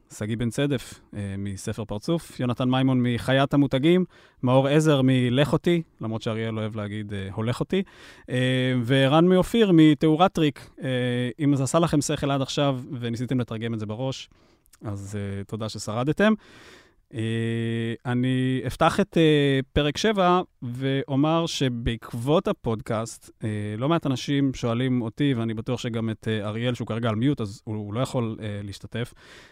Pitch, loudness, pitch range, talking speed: 125 Hz, -24 LUFS, 110-145 Hz, 135 wpm